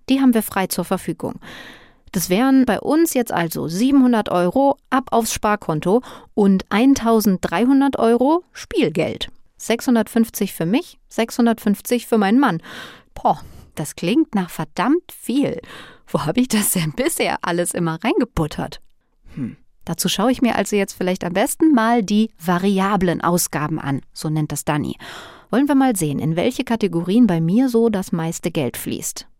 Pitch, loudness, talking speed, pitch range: 215 Hz, -19 LUFS, 155 wpm, 175-250 Hz